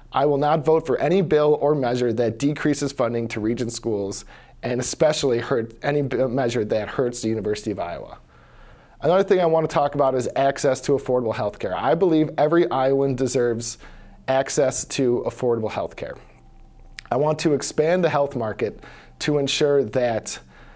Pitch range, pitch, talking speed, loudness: 115-150 Hz, 135 Hz, 170 wpm, -22 LUFS